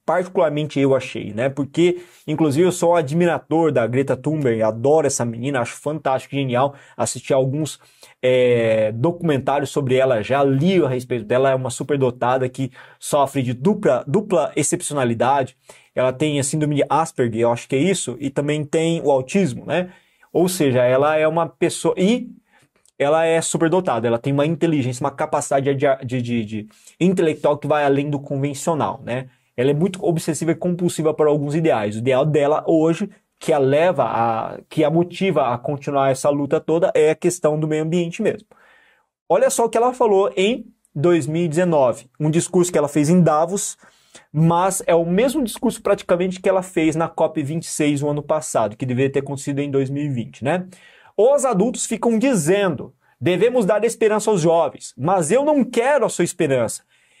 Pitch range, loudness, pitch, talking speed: 135-175 Hz, -19 LUFS, 155 Hz, 175 wpm